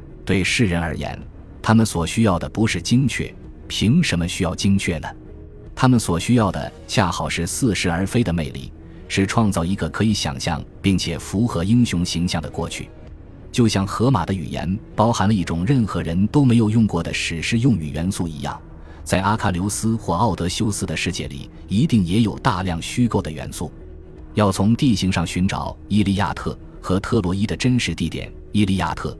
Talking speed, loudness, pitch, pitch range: 280 characters per minute, -20 LUFS, 95 Hz, 85-110 Hz